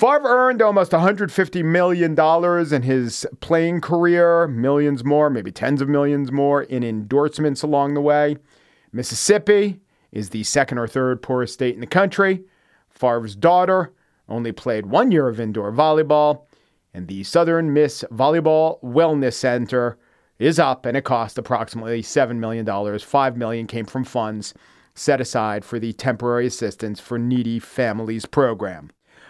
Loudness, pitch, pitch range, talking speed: -19 LUFS, 135 Hz, 115-160 Hz, 145 wpm